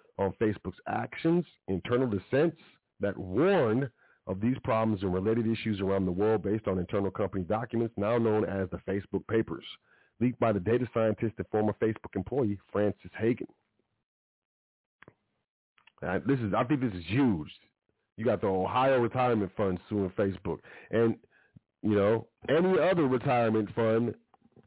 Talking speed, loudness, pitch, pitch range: 140 wpm, -30 LUFS, 110 Hz, 95-115 Hz